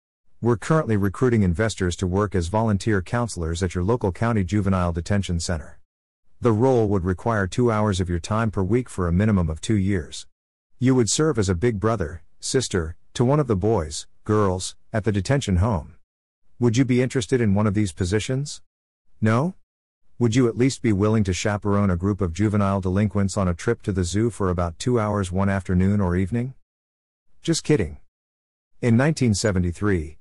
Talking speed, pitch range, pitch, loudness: 185 wpm, 90-115 Hz, 100 Hz, -22 LUFS